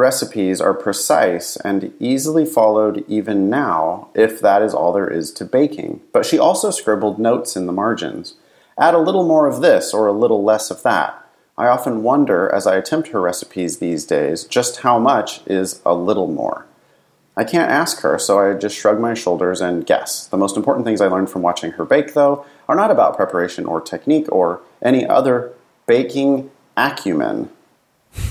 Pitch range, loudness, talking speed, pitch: 100-140 Hz, -17 LUFS, 185 wpm, 110 Hz